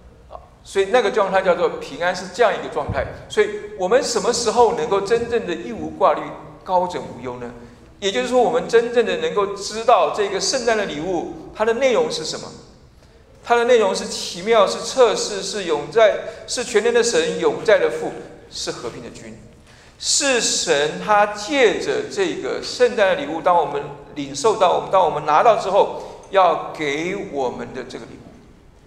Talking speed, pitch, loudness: 265 characters per minute, 235 Hz, -19 LUFS